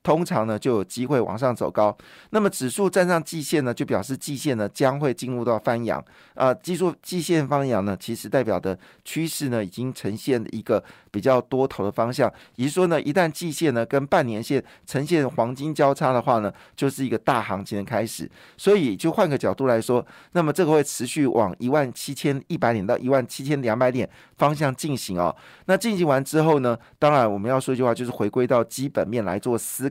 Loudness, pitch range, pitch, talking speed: -23 LUFS, 115-150 Hz, 130 Hz, 320 characters per minute